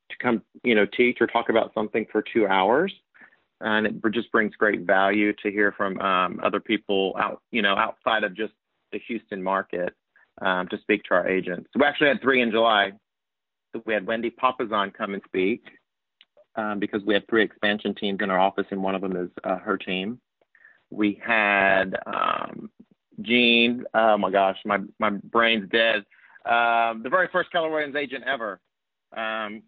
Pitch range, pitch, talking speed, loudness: 100-115 Hz, 110 Hz, 180 wpm, -23 LUFS